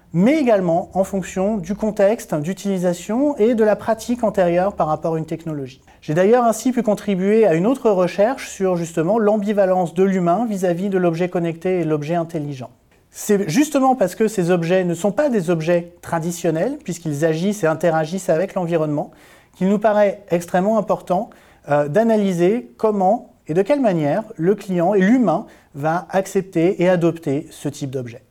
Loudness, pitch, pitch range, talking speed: -19 LUFS, 185 Hz, 170-210 Hz, 165 wpm